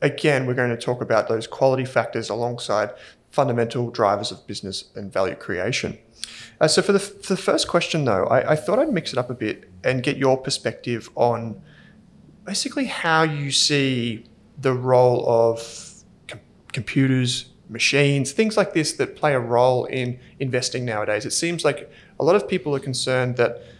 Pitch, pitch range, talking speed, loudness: 130 Hz, 120-155 Hz, 180 wpm, -22 LUFS